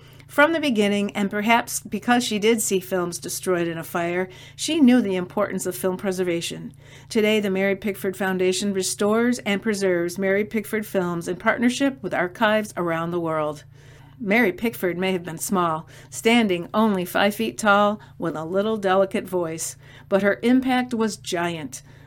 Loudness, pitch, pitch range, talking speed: -22 LUFS, 190 Hz, 170-215 Hz, 165 wpm